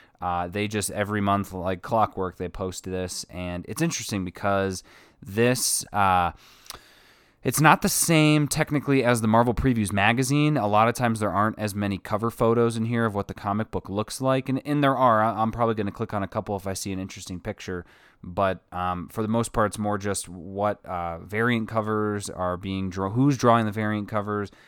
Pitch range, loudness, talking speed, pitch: 95-115 Hz, -25 LUFS, 205 wpm, 105 Hz